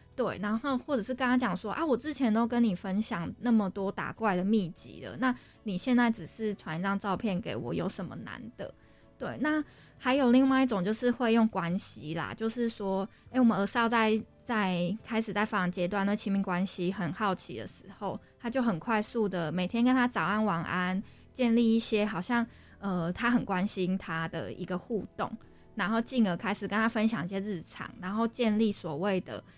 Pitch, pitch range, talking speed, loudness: 210 Hz, 190-235 Hz, 285 characters per minute, -30 LUFS